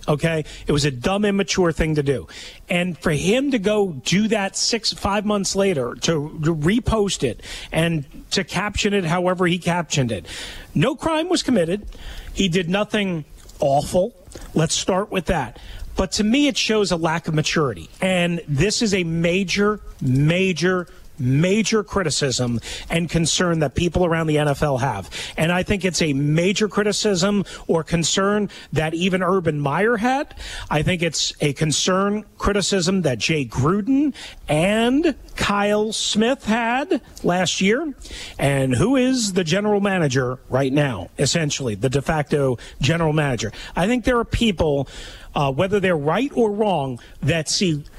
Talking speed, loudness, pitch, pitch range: 155 wpm, -20 LUFS, 180 Hz, 150-205 Hz